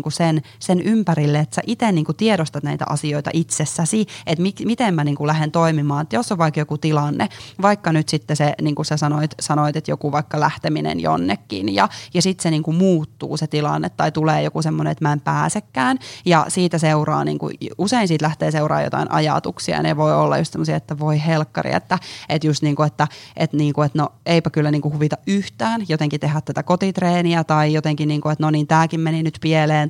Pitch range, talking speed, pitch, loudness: 145-165 Hz, 215 wpm, 155 Hz, -19 LUFS